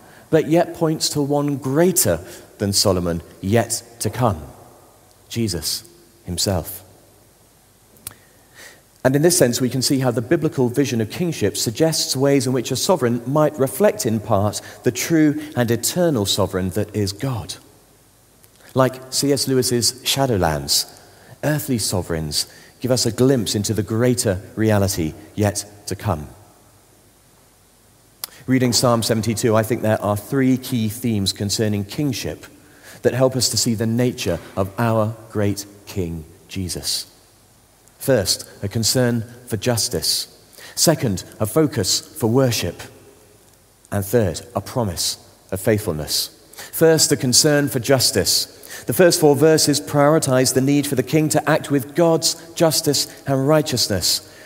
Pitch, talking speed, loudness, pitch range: 120 Hz, 135 wpm, -19 LUFS, 105-135 Hz